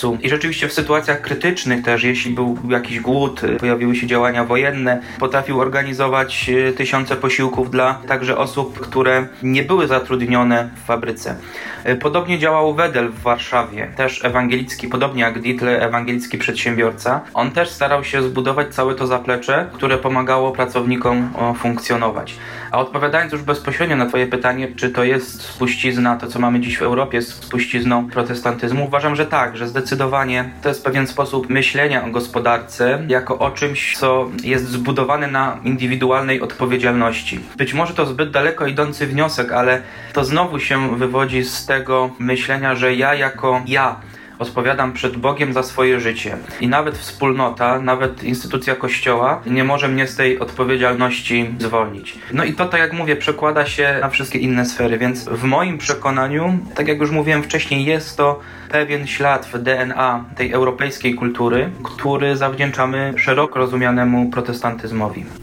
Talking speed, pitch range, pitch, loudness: 150 wpm, 120-140 Hz, 130 Hz, -17 LUFS